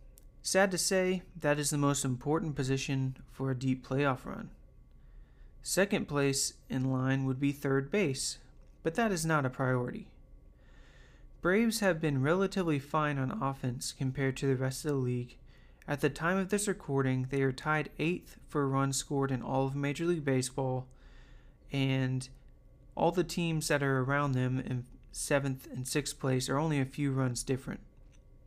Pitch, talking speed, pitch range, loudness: 135 Hz, 170 wpm, 130-155 Hz, -32 LUFS